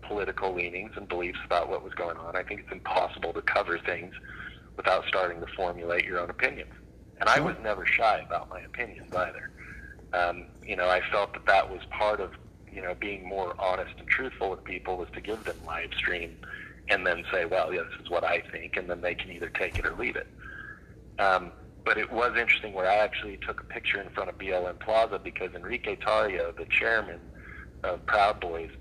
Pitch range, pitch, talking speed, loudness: 85-100 Hz, 90 Hz, 210 wpm, -29 LUFS